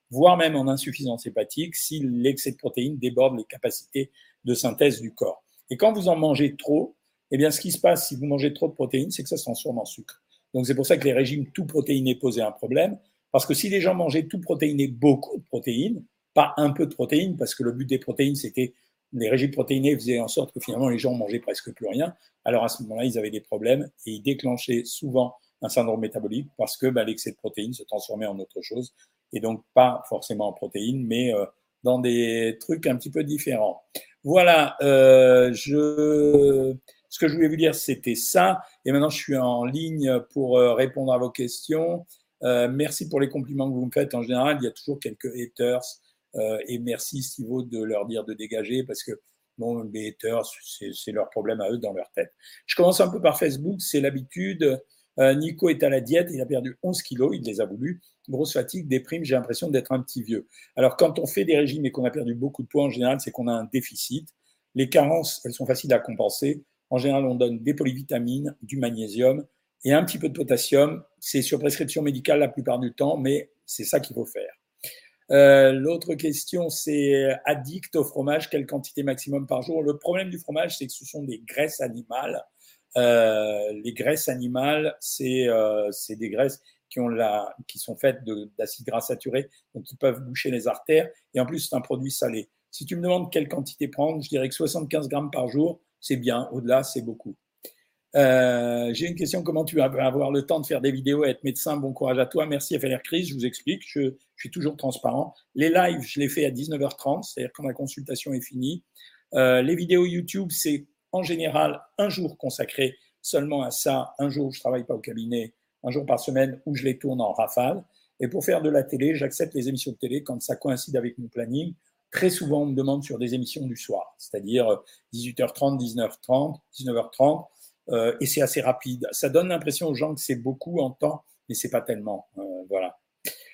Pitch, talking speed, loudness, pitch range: 135 Hz, 215 wpm, -25 LUFS, 125-150 Hz